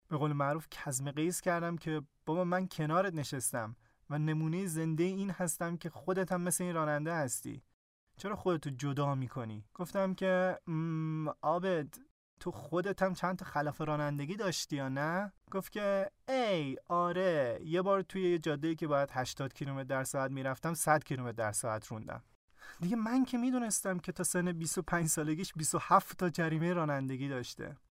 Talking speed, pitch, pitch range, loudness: 160 wpm, 165 Hz, 145-185 Hz, -35 LUFS